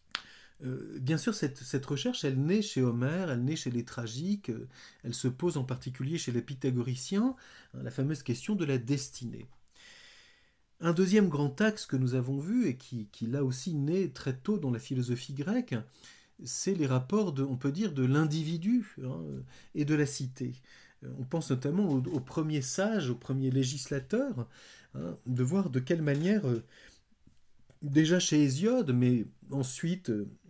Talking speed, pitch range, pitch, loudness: 170 wpm, 130-170 Hz, 140 Hz, -32 LUFS